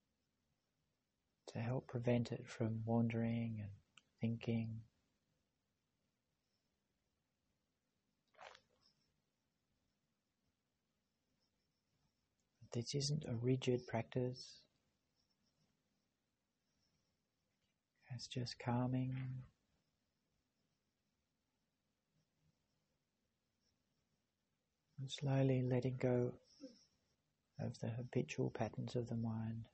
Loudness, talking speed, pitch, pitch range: -42 LUFS, 55 wpm, 125 Hz, 115-130 Hz